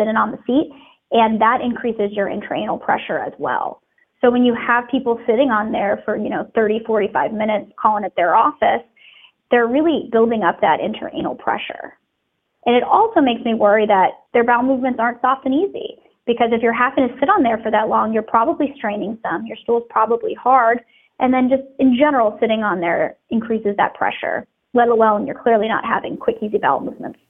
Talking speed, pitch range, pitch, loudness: 205 wpm, 220-270 Hz, 240 Hz, -18 LUFS